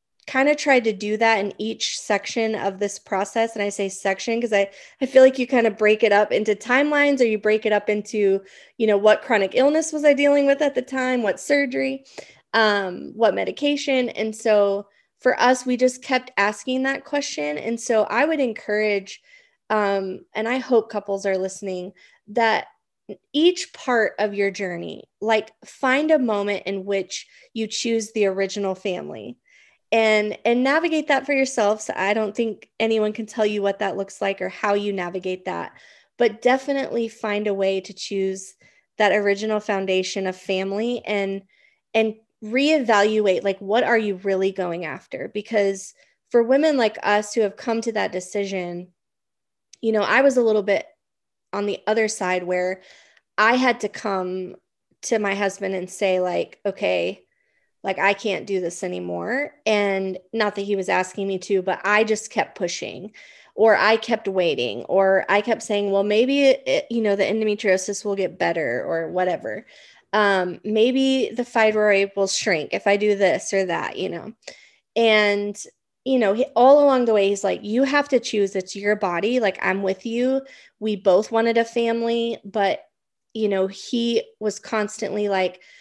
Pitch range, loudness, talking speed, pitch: 195-235 Hz, -21 LUFS, 180 wpm, 210 Hz